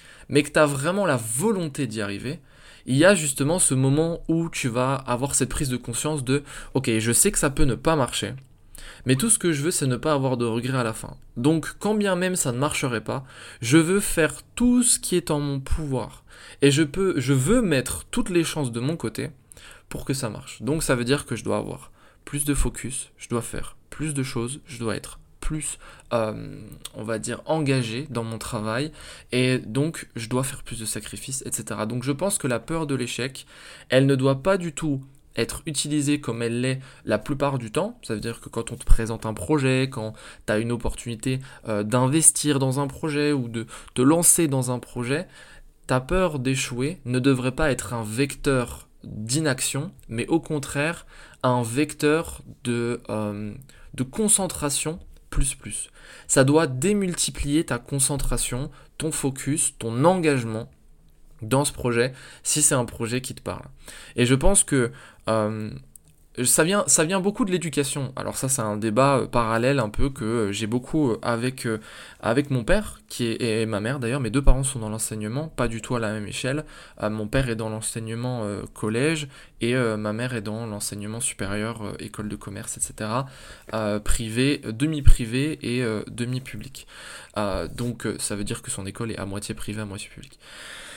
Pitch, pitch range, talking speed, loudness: 130 Hz, 115-145 Hz, 200 wpm, -24 LUFS